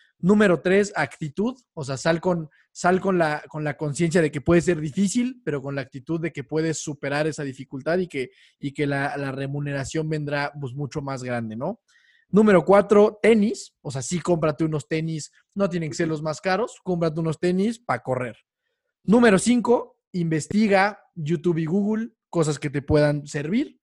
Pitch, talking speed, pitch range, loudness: 165 Hz, 180 wpm, 145-195 Hz, -23 LUFS